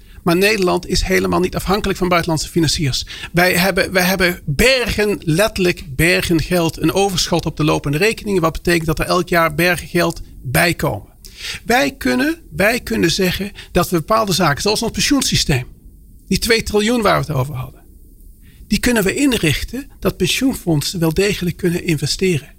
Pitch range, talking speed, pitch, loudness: 160-200 Hz, 160 wpm, 180 Hz, -16 LUFS